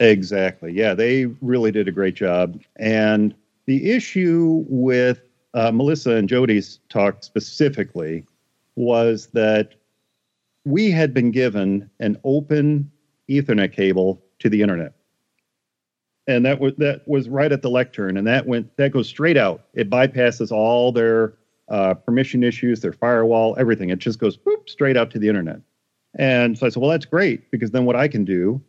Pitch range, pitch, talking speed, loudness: 105-135 Hz, 120 Hz, 165 wpm, -19 LUFS